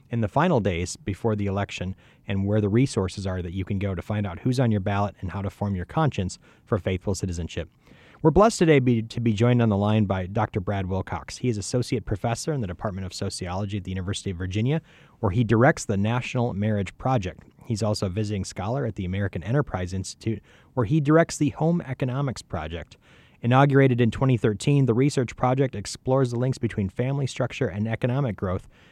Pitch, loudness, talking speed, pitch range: 110 Hz, -25 LUFS, 205 wpm, 100-130 Hz